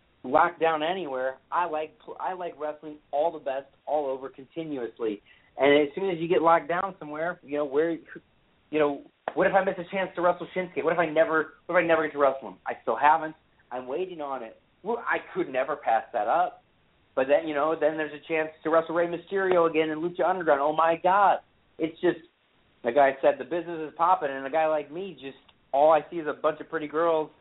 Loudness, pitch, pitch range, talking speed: -26 LUFS, 155 Hz, 145-170 Hz, 230 wpm